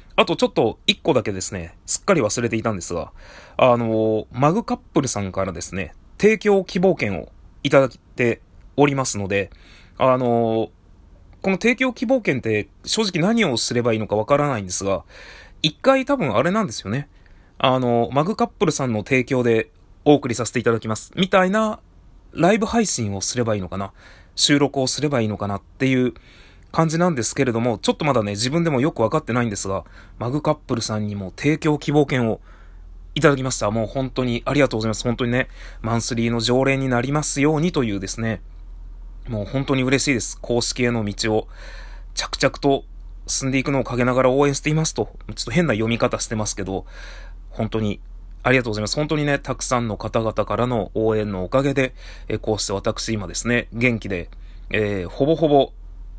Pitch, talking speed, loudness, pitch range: 115 Hz, 390 characters per minute, -20 LUFS, 100-140 Hz